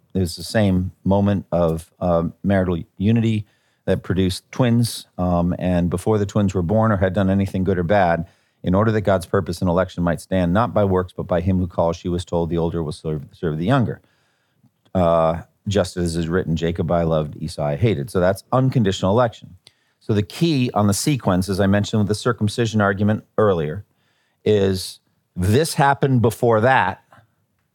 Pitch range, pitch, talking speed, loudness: 85-110 Hz, 95 Hz, 185 wpm, -20 LUFS